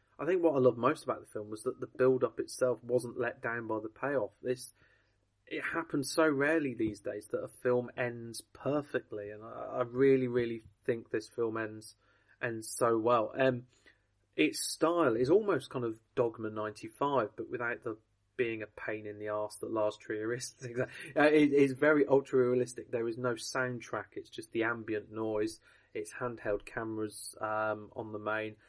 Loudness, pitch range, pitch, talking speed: -33 LUFS, 110-130 Hz, 115 Hz, 180 wpm